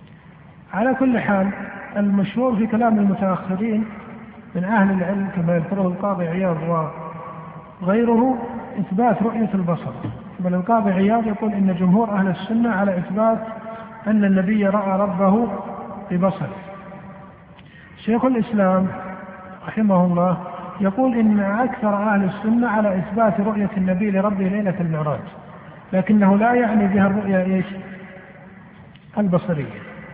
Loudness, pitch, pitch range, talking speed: -20 LUFS, 195 Hz, 185-215 Hz, 110 wpm